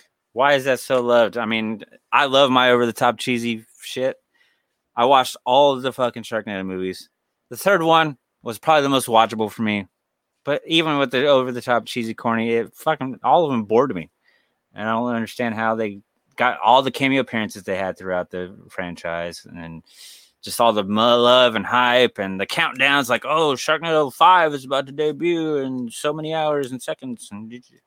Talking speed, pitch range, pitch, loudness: 190 wpm, 110-140 Hz, 120 Hz, -19 LUFS